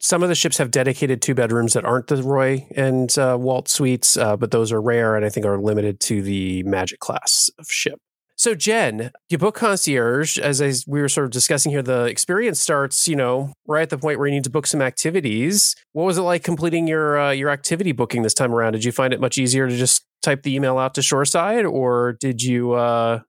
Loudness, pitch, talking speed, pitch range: -19 LUFS, 135 Hz, 240 wpm, 120-155 Hz